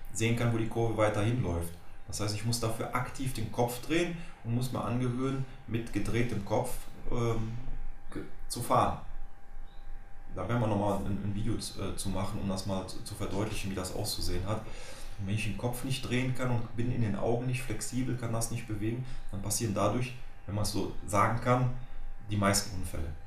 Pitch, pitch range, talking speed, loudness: 110 Hz, 100-120 Hz, 190 wpm, -33 LUFS